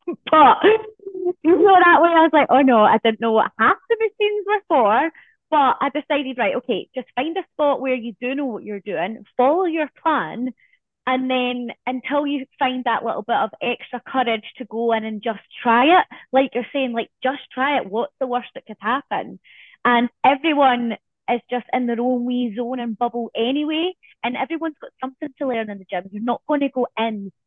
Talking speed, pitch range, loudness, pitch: 210 wpm, 235-305 Hz, -20 LUFS, 255 Hz